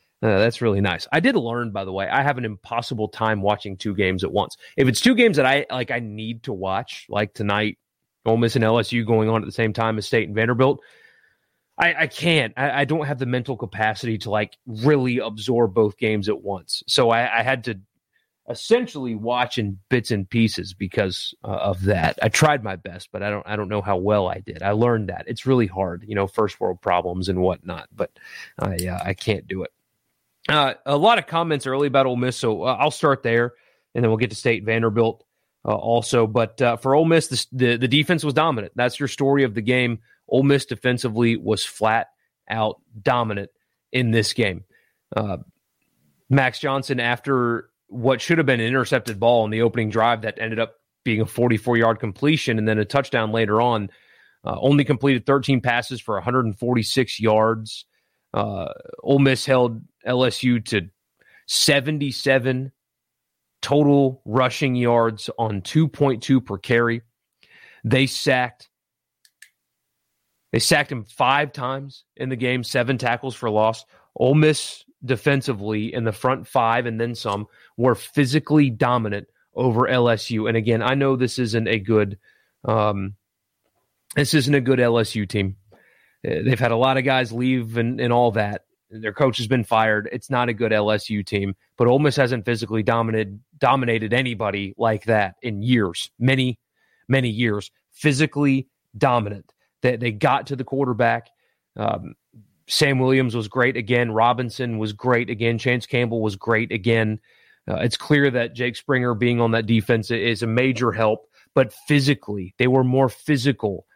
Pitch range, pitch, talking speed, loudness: 110-130 Hz, 120 Hz, 180 wpm, -21 LUFS